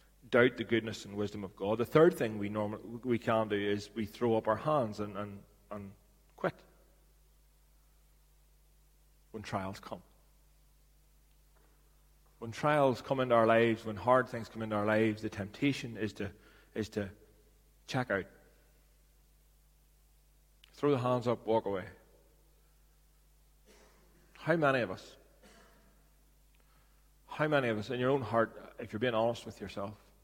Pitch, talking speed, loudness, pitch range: 110 Hz, 145 wpm, -33 LUFS, 105-120 Hz